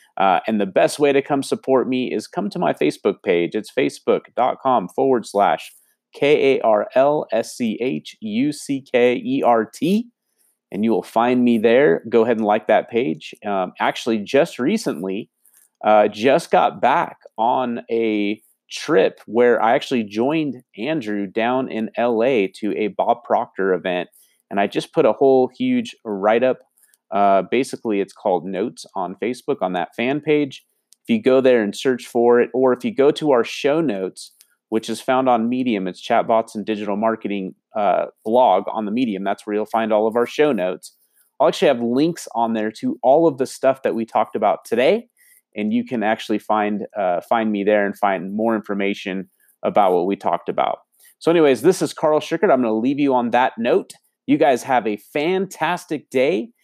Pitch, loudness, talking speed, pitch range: 120 Hz, -19 LUFS, 195 wpm, 105-140 Hz